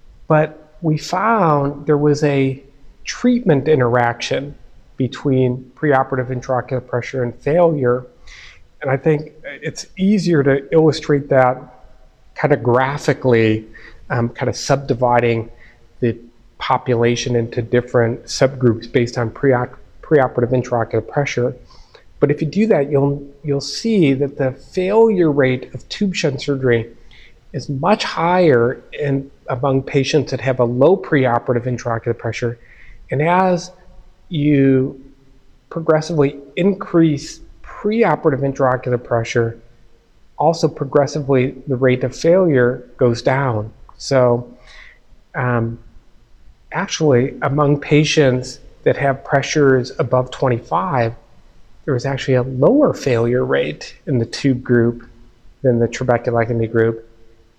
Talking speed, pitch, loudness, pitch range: 115 wpm, 130 Hz, -17 LUFS, 120-150 Hz